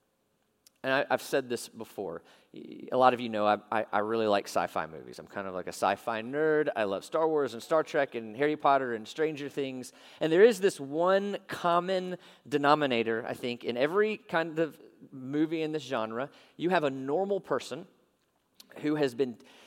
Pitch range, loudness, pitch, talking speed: 120-165 Hz, -30 LUFS, 145 Hz, 190 wpm